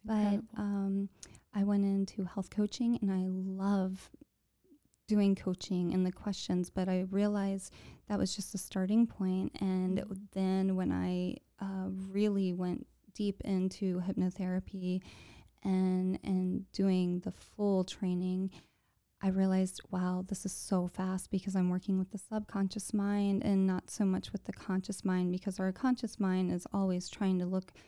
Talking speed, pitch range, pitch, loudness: 155 wpm, 185-200 Hz, 190 Hz, -34 LUFS